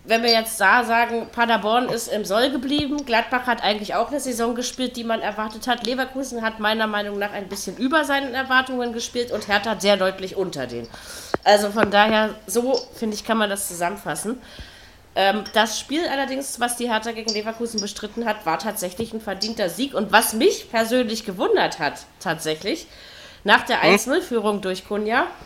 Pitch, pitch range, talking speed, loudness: 225 Hz, 205-245 Hz, 180 wpm, -22 LUFS